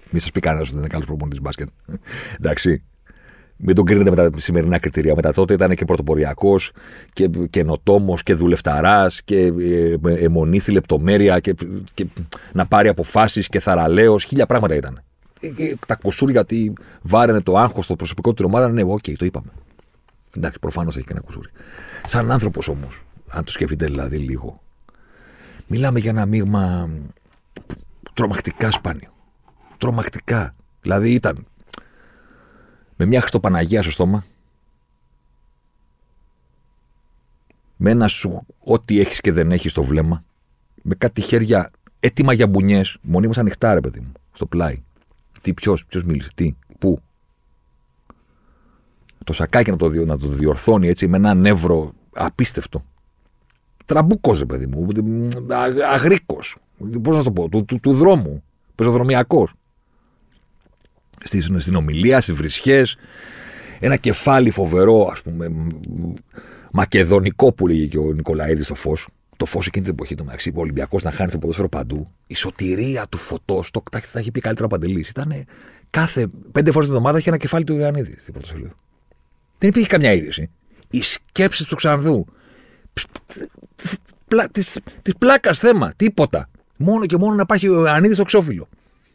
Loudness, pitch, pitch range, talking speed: -18 LUFS, 95 Hz, 80-115 Hz, 150 wpm